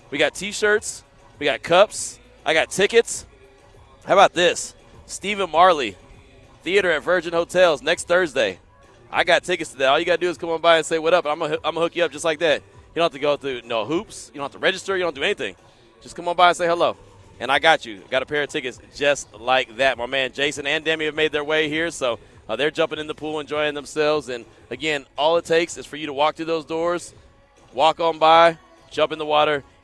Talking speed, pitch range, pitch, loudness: 250 wpm, 145-170 Hz, 155 Hz, -21 LUFS